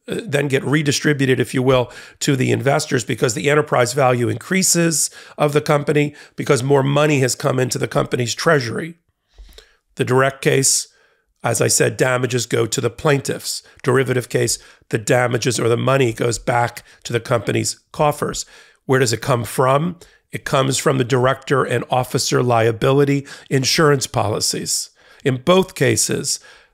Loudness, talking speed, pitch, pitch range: -18 LUFS, 155 wpm, 135 Hz, 125-145 Hz